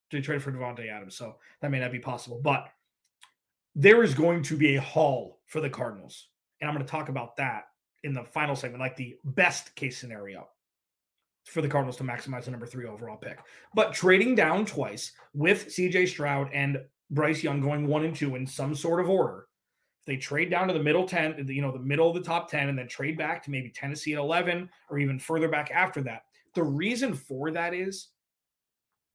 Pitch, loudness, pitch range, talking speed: 145 Hz, -28 LUFS, 135-165 Hz, 210 wpm